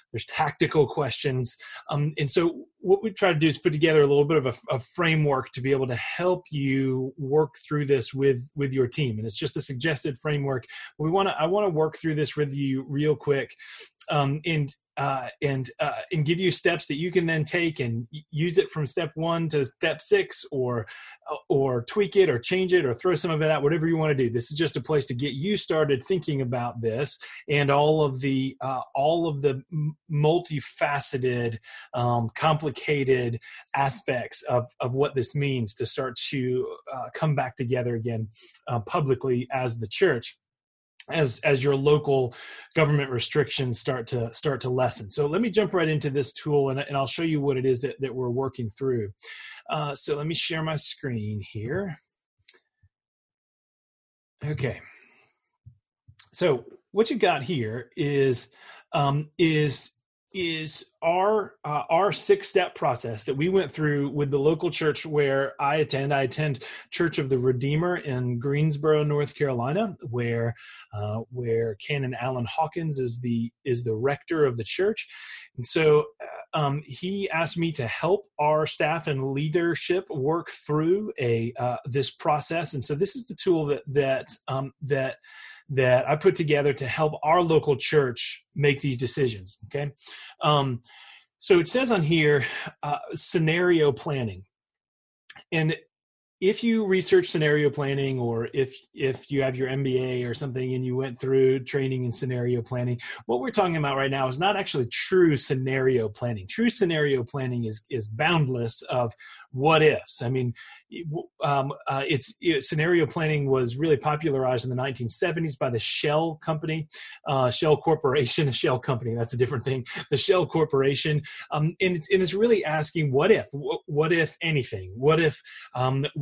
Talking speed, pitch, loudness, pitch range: 175 wpm, 145 Hz, -26 LUFS, 130-160 Hz